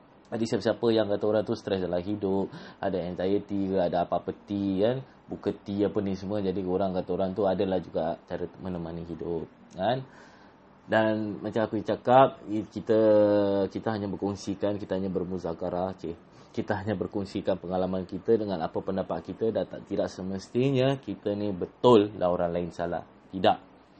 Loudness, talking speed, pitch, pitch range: -28 LUFS, 165 wpm, 100 Hz, 95-105 Hz